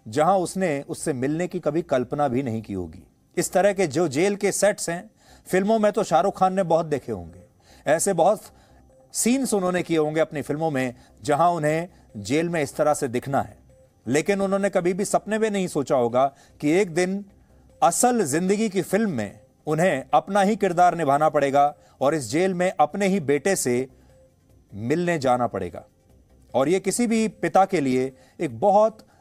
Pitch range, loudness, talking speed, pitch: 135-195 Hz, -23 LUFS, 185 wpm, 165 Hz